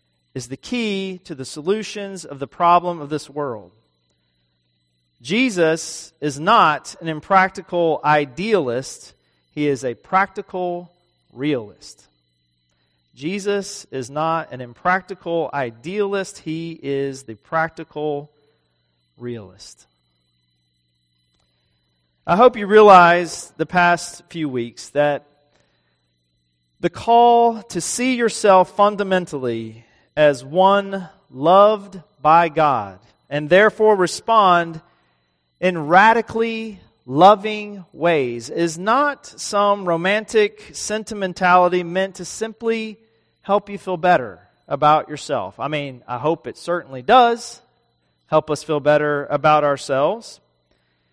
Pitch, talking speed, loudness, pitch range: 160 Hz, 105 wpm, -18 LUFS, 125-195 Hz